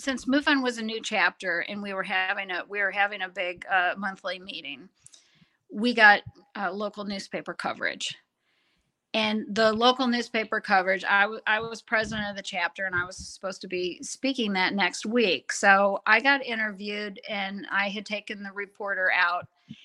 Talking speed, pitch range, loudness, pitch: 180 wpm, 195-225 Hz, -26 LUFS, 205 Hz